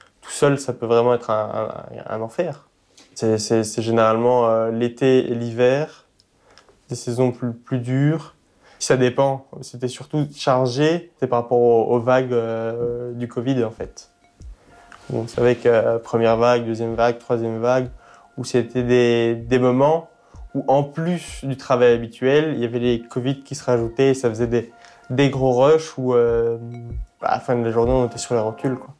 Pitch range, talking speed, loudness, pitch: 115-130 Hz, 185 wpm, -20 LUFS, 120 Hz